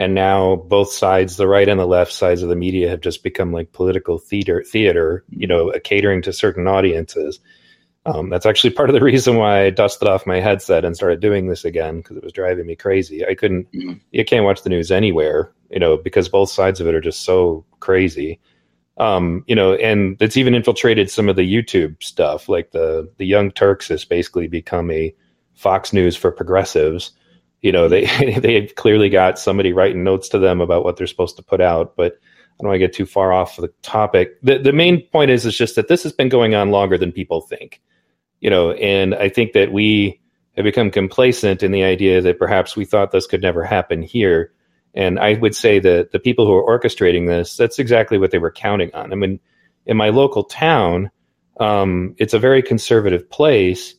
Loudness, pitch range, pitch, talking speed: -16 LUFS, 90-120 Hz, 95 Hz, 210 wpm